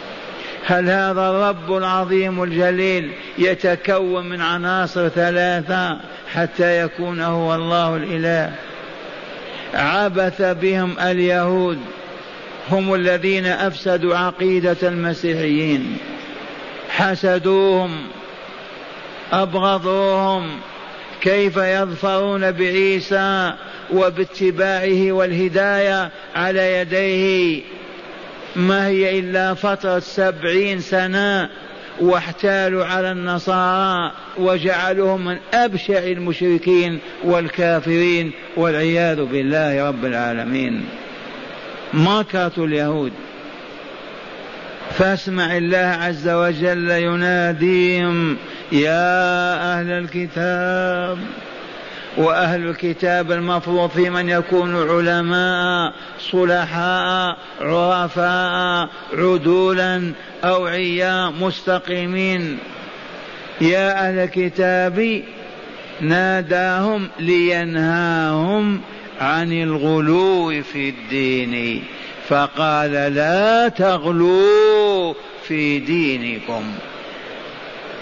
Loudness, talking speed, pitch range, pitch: -18 LUFS, 65 wpm, 170-190 Hz, 180 Hz